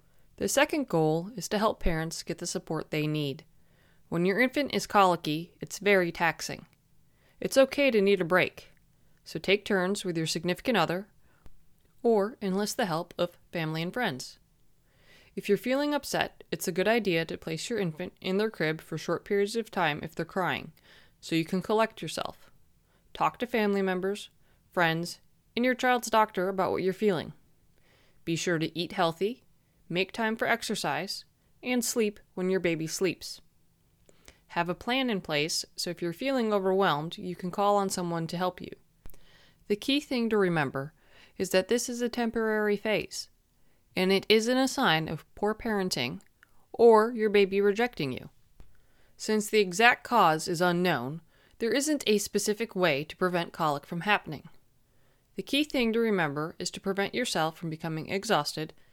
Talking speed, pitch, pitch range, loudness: 170 wpm, 190 Hz, 165-215 Hz, -28 LUFS